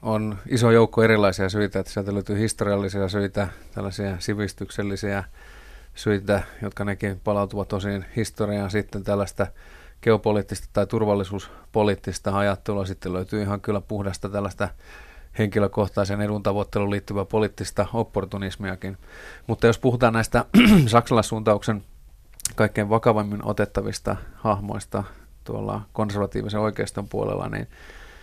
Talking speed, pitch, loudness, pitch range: 105 wpm, 105 Hz, -24 LUFS, 100-110 Hz